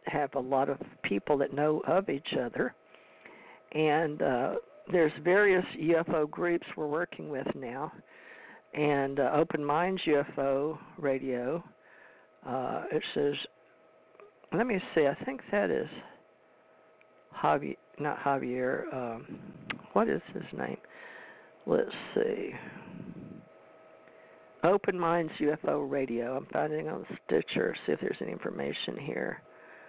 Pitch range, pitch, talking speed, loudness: 140-170 Hz, 150 Hz, 120 wpm, -31 LUFS